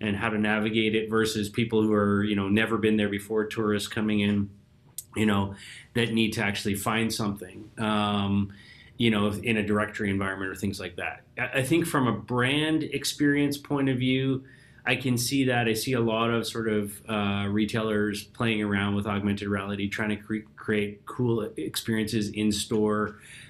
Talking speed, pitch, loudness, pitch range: 185 wpm, 110 Hz, -27 LUFS, 105-120 Hz